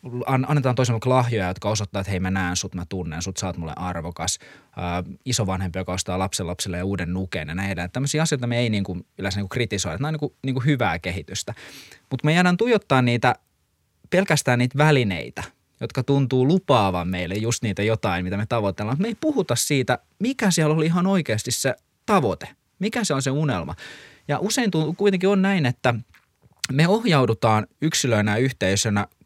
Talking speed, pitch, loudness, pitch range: 190 wpm, 120 Hz, -23 LUFS, 95-145 Hz